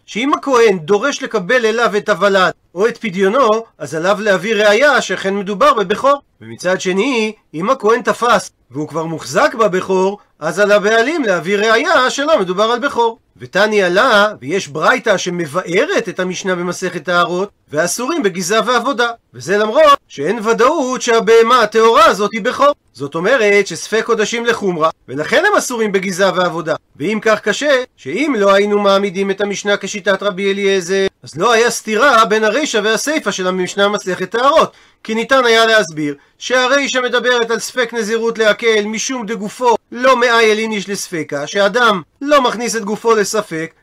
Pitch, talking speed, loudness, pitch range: 210 Hz, 150 wpm, -14 LUFS, 190-235 Hz